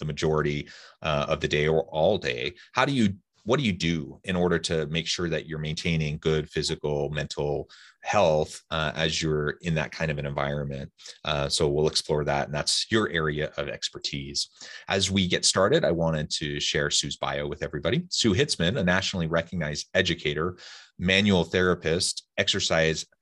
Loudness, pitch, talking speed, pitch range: -26 LUFS, 80 Hz, 180 wpm, 75-85 Hz